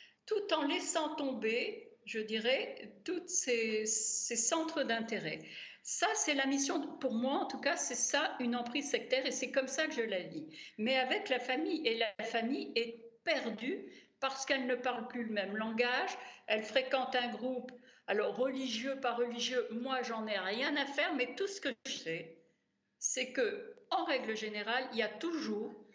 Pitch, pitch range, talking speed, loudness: 255 Hz, 230-285 Hz, 185 wpm, -35 LUFS